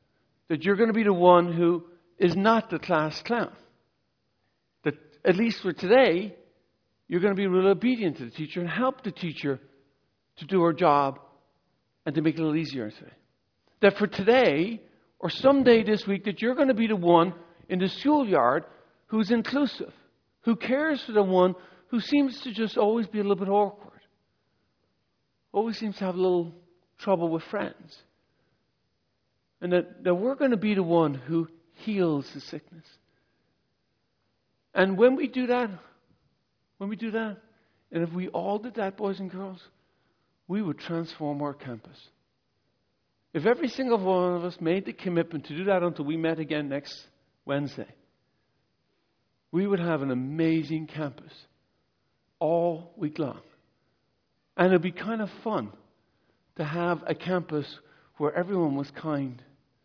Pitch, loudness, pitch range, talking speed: 180 Hz, -26 LUFS, 155-210 Hz, 165 wpm